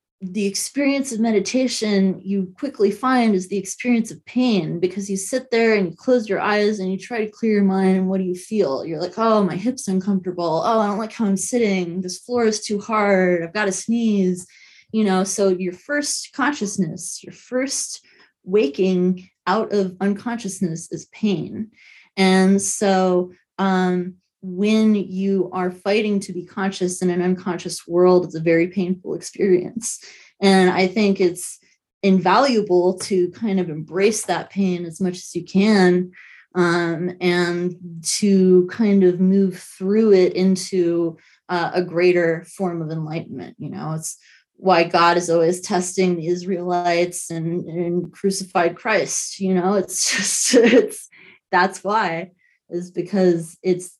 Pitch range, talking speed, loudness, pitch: 180-205 Hz, 160 wpm, -20 LUFS, 185 Hz